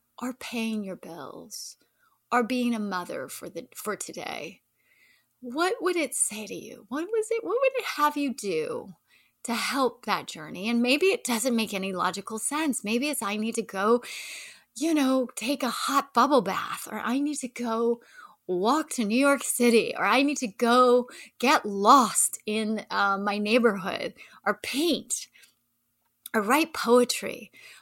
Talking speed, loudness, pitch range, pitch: 170 wpm, -26 LUFS, 220-285 Hz, 245 Hz